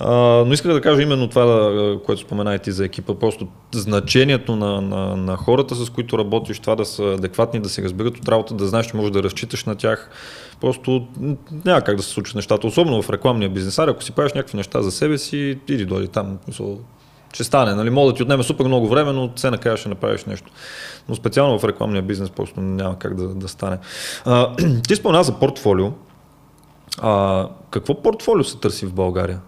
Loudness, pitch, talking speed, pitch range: -19 LUFS, 110 Hz, 200 wpm, 100-130 Hz